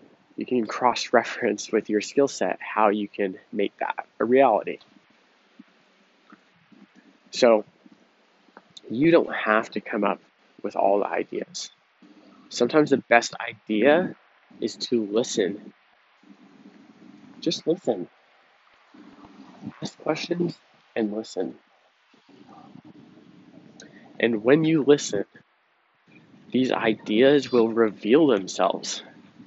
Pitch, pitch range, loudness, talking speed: 120 Hz, 110-145 Hz, -24 LUFS, 100 wpm